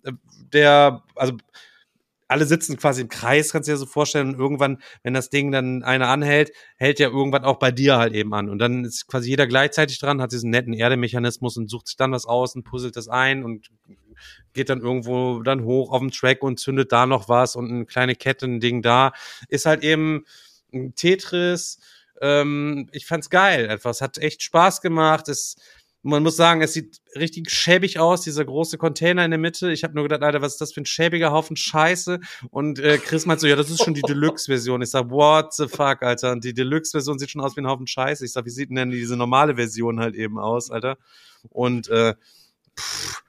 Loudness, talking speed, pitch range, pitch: -20 LUFS, 215 wpm, 125-155 Hz, 135 Hz